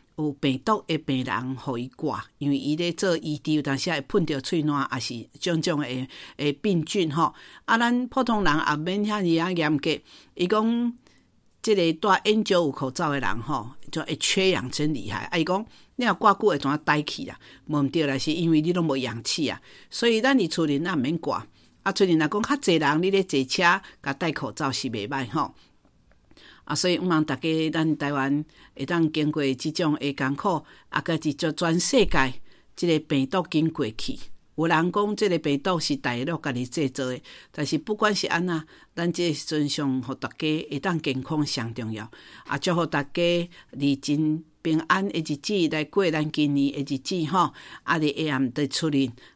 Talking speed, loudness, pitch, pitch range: 265 characters per minute, -25 LUFS, 155 Hz, 140-175 Hz